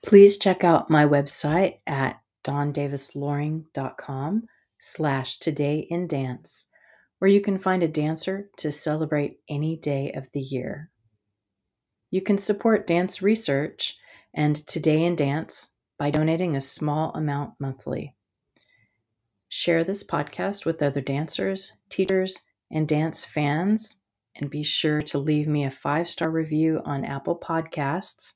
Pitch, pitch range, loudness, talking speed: 155 Hz, 145-175 Hz, -25 LUFS, 130 wpm